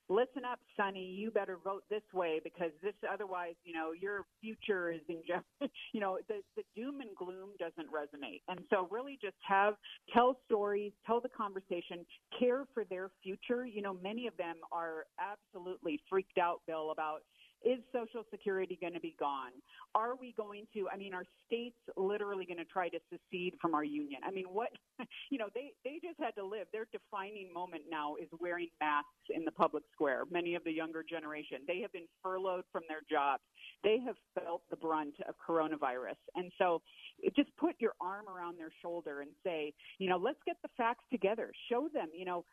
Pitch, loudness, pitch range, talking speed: 190 Hz, -39 LUFS, 170-225 Hz, 195 wpm